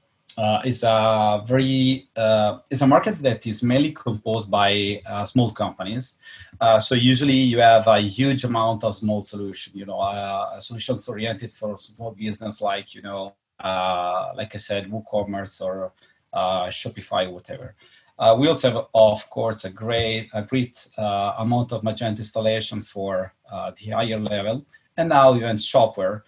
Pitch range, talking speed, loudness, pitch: 100-120 Hz, 160 wpm, -21 LUFS, 110 Hz